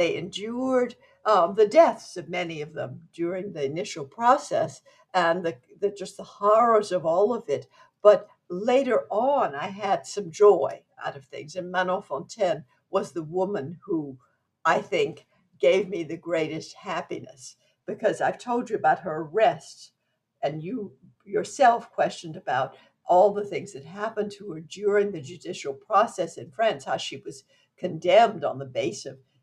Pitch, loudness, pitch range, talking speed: 200 Hz, -25 LUFS, 170-235 Hz, 165 wpm